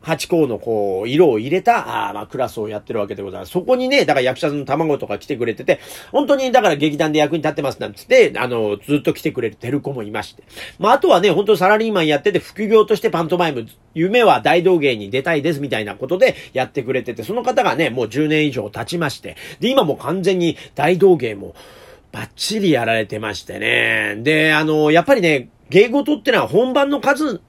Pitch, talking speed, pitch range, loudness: 160 Hz, 430 characters per minute, 140-200 Hz, -17 LUFS